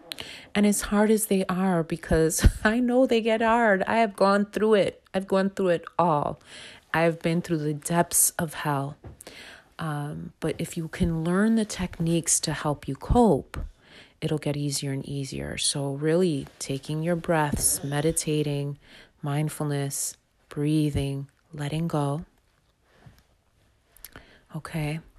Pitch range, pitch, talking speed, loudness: 145-185 Hz, 160 Hz, 140 wpm, -25 LUFS